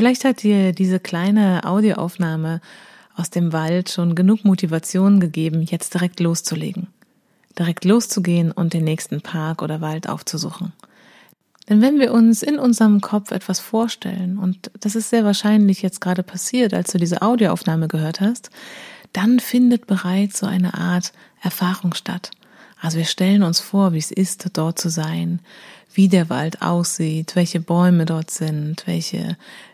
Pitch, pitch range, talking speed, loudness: 185 Hz, 170-210 Hz, 155 wpm, -19 LUFS